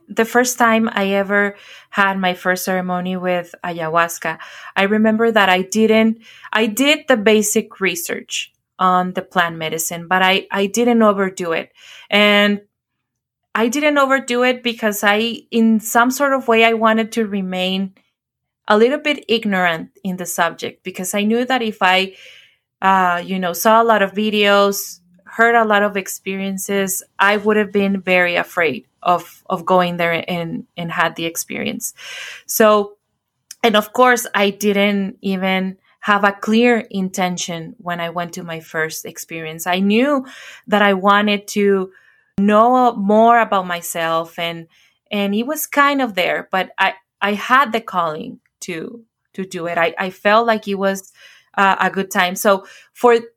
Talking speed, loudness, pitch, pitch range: 160 wpm, -17 LUFS, 200 Hz, 185-225 Hz